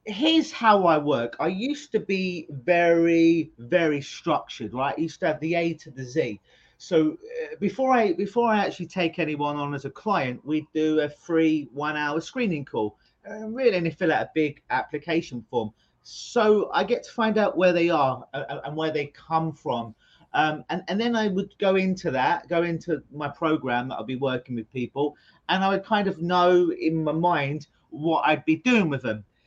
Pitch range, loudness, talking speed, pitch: 145-190 Hz, -25 LUFS, 205 wpm, 165 Hz